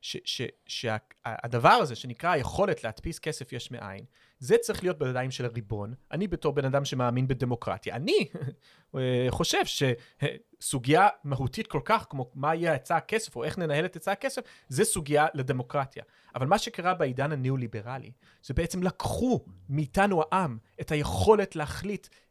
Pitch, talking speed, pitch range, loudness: 145 Hz, 145 wpm, 125-180 Hz, -28 LUFS